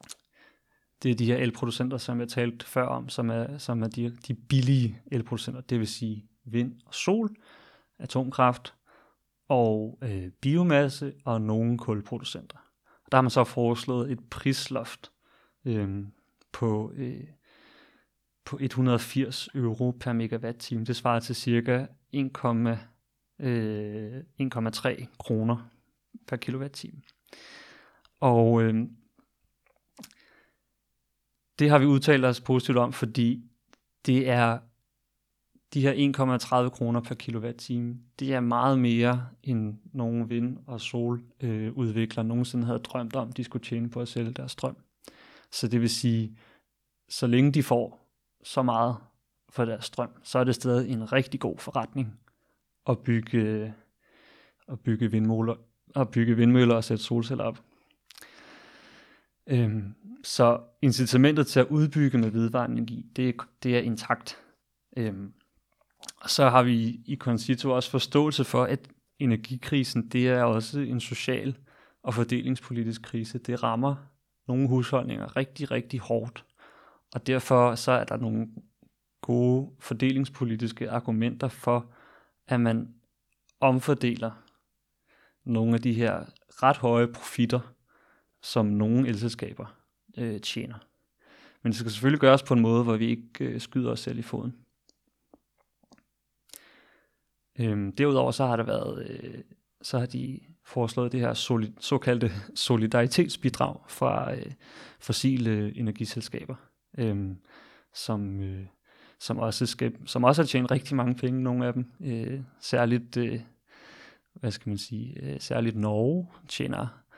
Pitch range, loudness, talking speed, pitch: 115-130 Hz, -27 LUFS, 130 wpm, 120 Hz